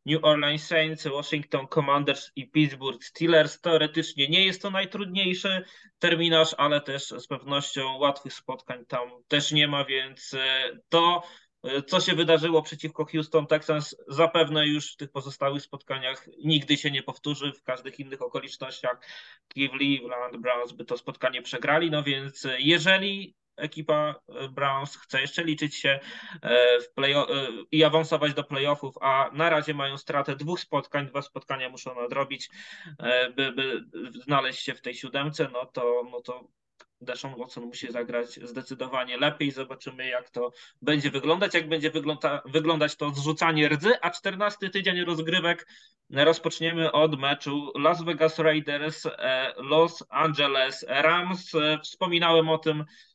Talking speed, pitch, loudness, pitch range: 140 wpm, 145 Hz, -26 LUFS, 135-160 Hz